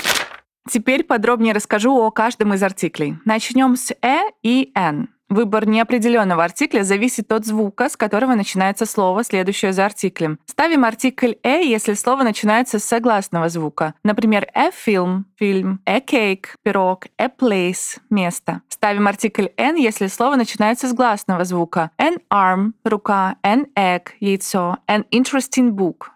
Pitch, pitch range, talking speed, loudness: 215 Hz, 195-245 Hz, 140 wpm, -18 LUFS